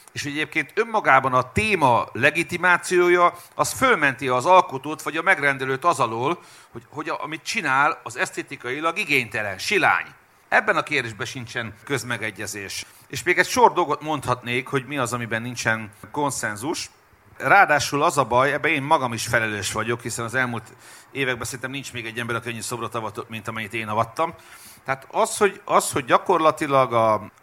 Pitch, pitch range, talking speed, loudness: 130 Hz, 115-155 Hz, 165 wpm, -22 LUFS